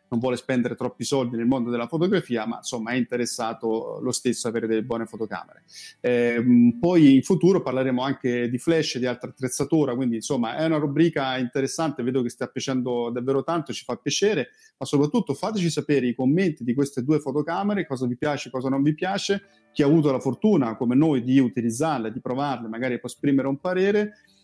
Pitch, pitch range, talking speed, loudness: 130 Hz, 120-160 Hz, 195 wpm, -24 LUFS